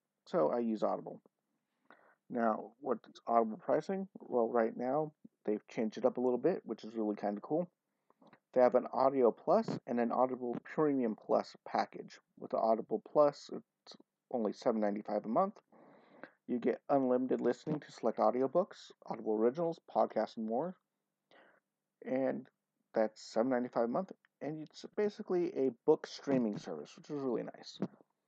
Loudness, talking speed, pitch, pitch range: -35 LUFS, 155 wpm, 125 Hz, 115-155 Hz